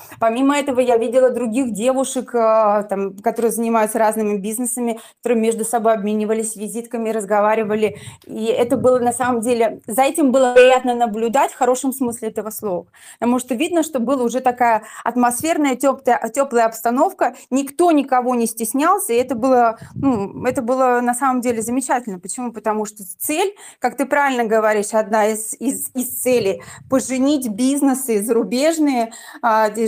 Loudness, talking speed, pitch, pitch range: -18 LUFS, 150 wpm, 240 Hz, 225-260 Hz